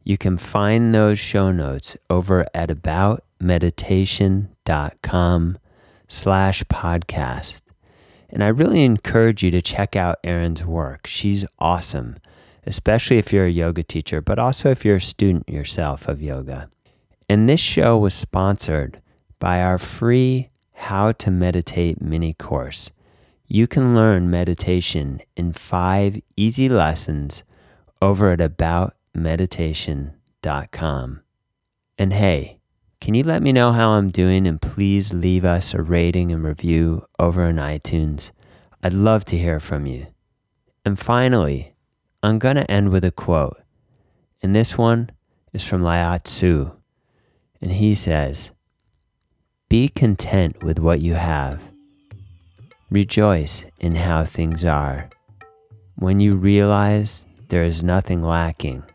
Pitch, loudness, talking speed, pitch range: 90 Hz, -19 LUFS, 130 wpm, 85-105 Hz